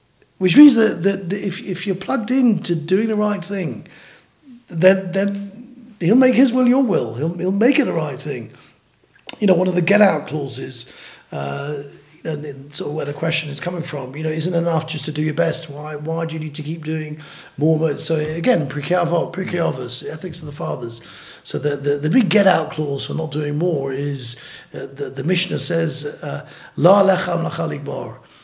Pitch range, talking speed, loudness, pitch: 150-195 Hz, 200 wpm, -19 LUFS, 165 Hz